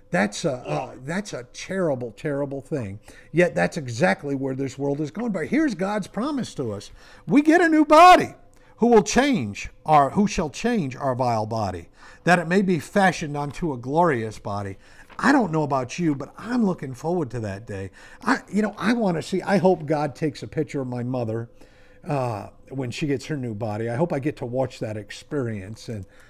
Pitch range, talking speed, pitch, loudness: 120-185 Hz, 205 wpm, 145 Hz, -23 LUFS